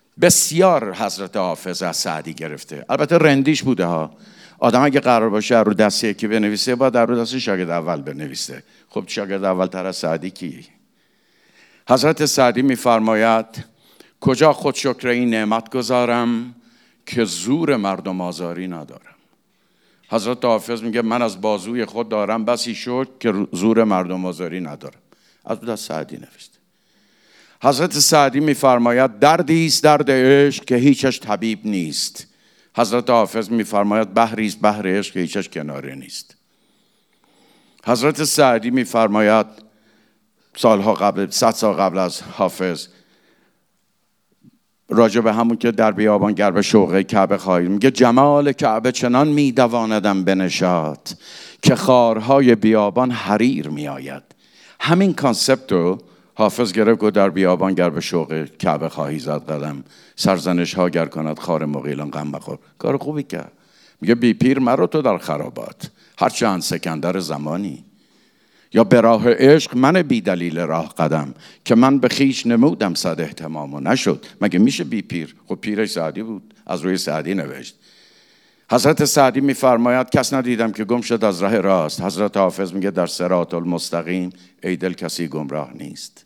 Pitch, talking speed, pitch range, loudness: 110 Hz, 145 wpm, 90-125 Hz, -18 LUFS